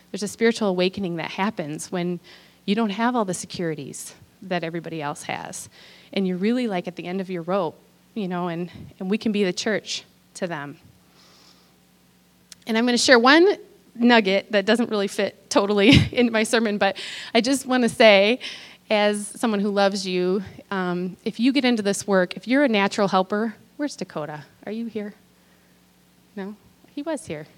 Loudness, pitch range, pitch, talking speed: -22 LUFS, 180-225 Hz, 200 Hz, 185 wpm